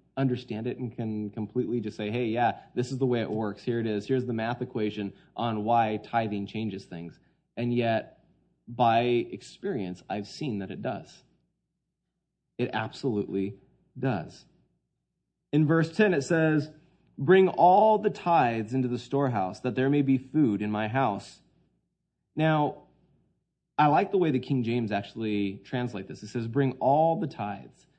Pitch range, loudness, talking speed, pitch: 105-135 Hz, -28 LUFS, 165 wpm, 120 Hz